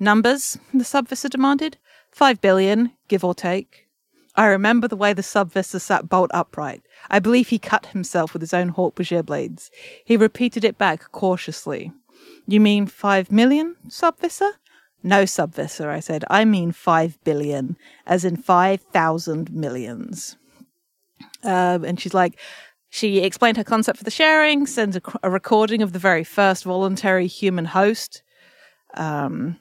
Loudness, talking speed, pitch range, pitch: -20 LUFS, 150 wpm, 180-235 Hz, 200 Hz